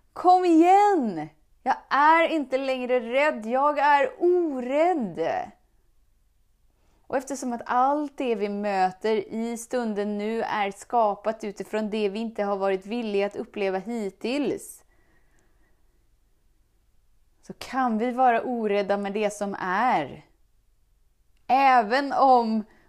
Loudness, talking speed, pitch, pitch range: -24 LUFS, 115 wpm, 235 Hz, 205-280 Hz